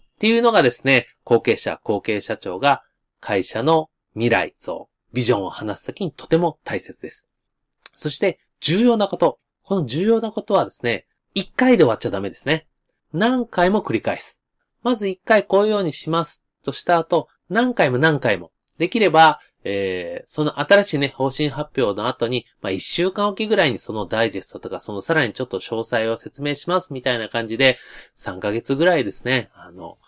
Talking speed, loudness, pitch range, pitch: 350 characters per minute, -20 LUFS, 120-190 Hz, 150 Hz